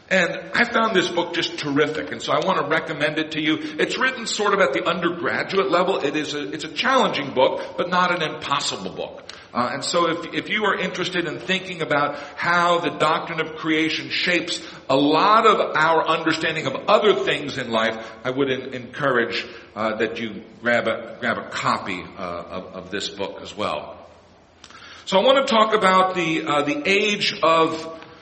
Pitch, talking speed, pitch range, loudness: 160 Hz, 195 wpm, 145-180 Hz, -21 LUFS